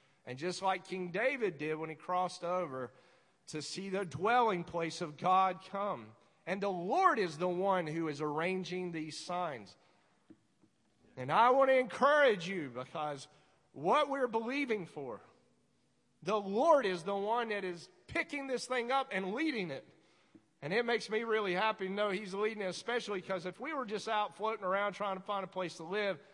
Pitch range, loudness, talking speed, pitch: 175-220 Hz, -34 LUFS, 185 wpm, 190 Hz